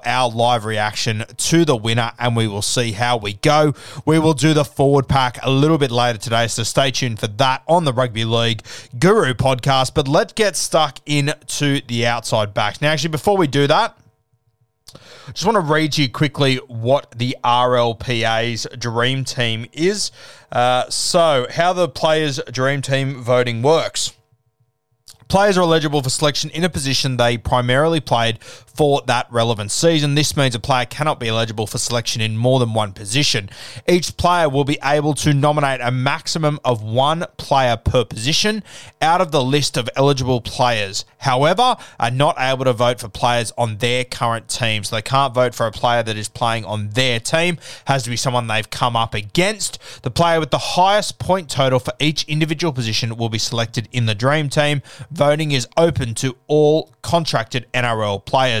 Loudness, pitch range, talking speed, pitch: -18 LUFS, 120-150 Hz, 185 wpm, 130 Hz